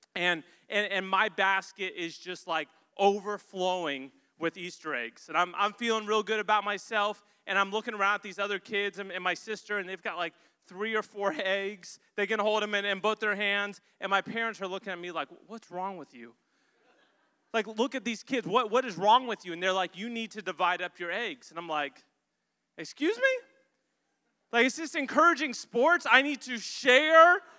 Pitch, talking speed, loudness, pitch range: 205 Hz, 210 wpm, -29 LUFS, 185-235 Hz